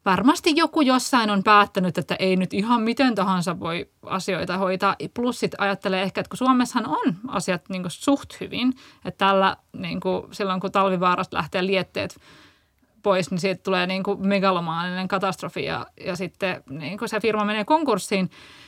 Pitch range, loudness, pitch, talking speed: 185-220 Hz, -23 LUFS, 195 Hz, 170 wpm